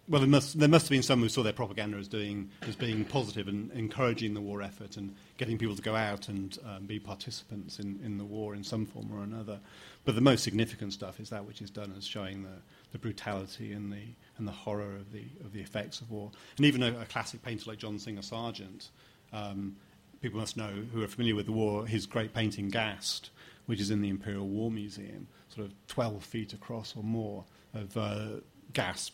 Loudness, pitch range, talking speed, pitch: -34 LUFS, 100-115 Hz, 220 wpm, 105 Hz